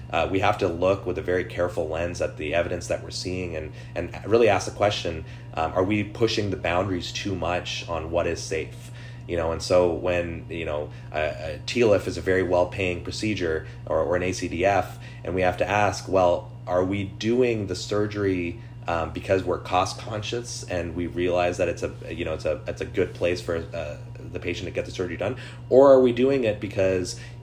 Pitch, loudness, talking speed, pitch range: 95 Hz, -25 LUFS, 210 wpm, 90-120 Hz